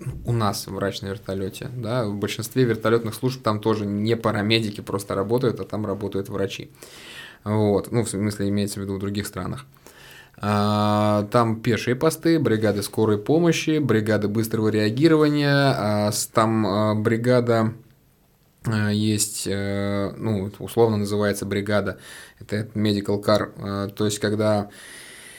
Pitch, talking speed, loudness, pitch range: 105 Hz, 125 wpm, -23 LUFS, 100-115 Hz